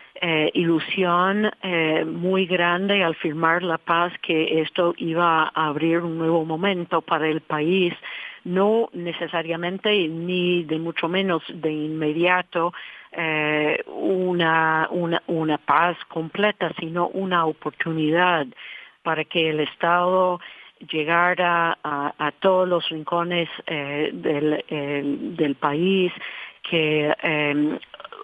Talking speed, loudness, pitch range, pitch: 115 wpm, -22 LUFS, 155-180 Hz, 165 Hz